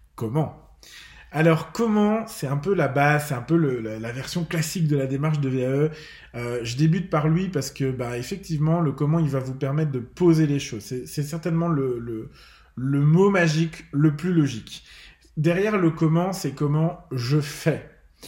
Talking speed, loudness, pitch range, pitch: 190 wpm, -23 LUFS, 135-165 Hz, 150 Hz